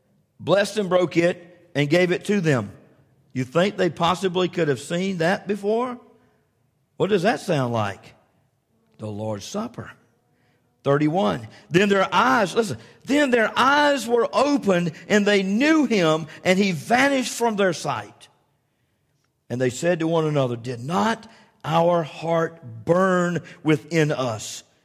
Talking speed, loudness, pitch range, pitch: 140 wpm, -22 LUFS, 140-205 Hz, 170 Hz